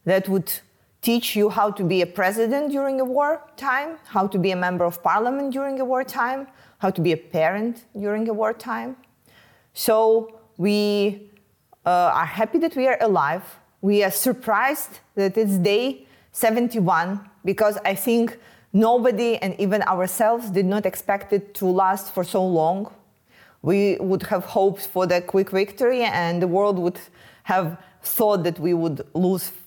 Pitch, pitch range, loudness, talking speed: 205 Hz, 190-235 Hz, -22 LUFS, 165 wpm